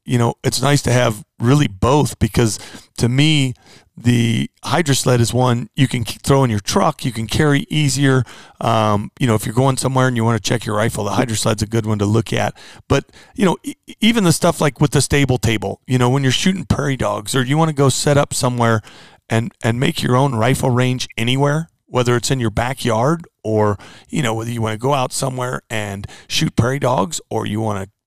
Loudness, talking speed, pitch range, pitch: -17 LUFS, 230 wpm, 110-140 Hz, 125 Hz